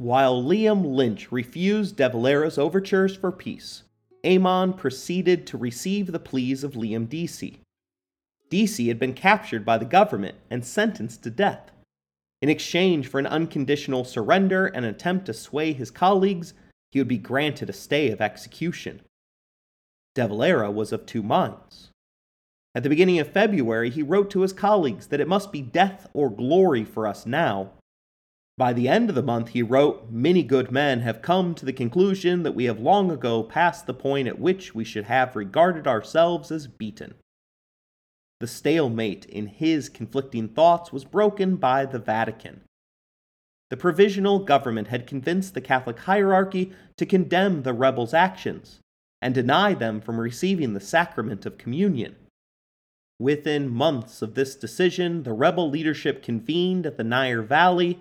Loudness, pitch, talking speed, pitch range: -23 LUFS, 140 Hz, 160 wpm, 120-180 Hz